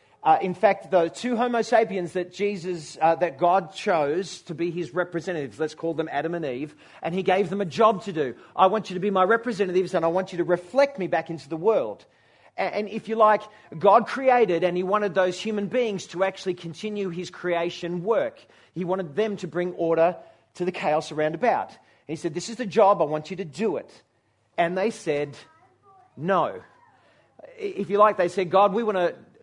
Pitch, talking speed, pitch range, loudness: 185 Hz, 210 wpm, 170-210 Hz, -24 LUFS